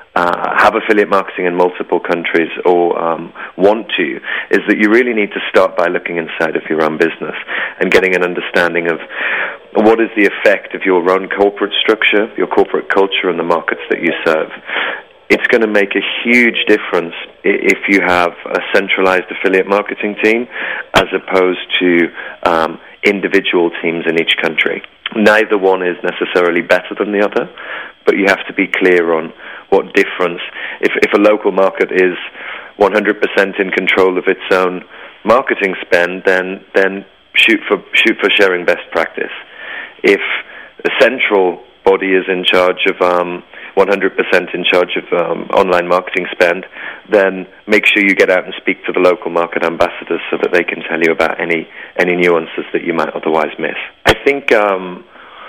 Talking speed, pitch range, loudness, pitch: 175 wpm, 90-100 Hz, -13 LUFS, 90 Hz